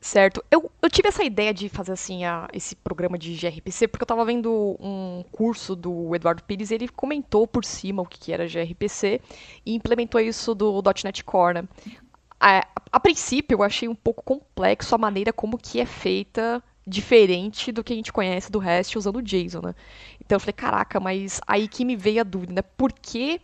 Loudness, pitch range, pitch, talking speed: -23 LUFS, 185-235 Hz, 210 Hz, 205 wpm